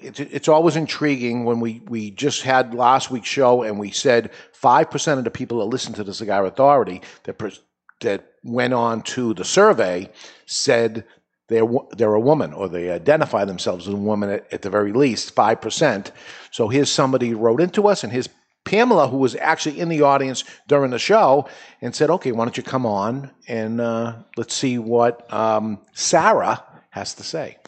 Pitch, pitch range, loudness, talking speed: 120 Hz, 115-140 Hz, -19 LUFS, 185 wpm